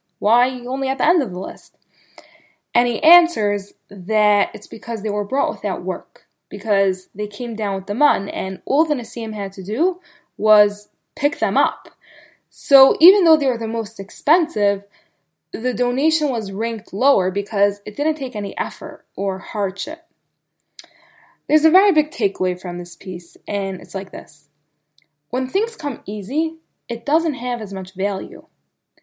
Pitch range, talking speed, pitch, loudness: 200-285 Hz, 165 wpm, 220 Hz, -20 LUFS